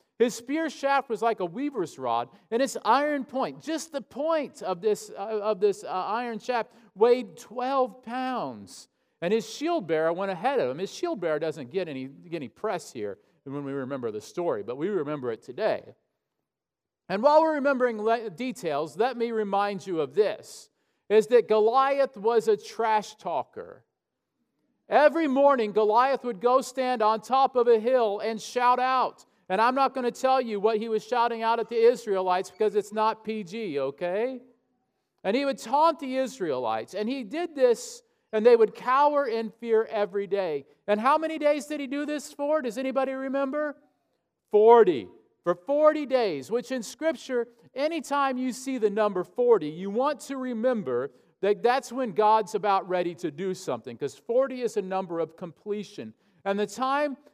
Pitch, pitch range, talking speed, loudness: 235 Hz, 210-275 Hz, 180 wpm, -26 LUFS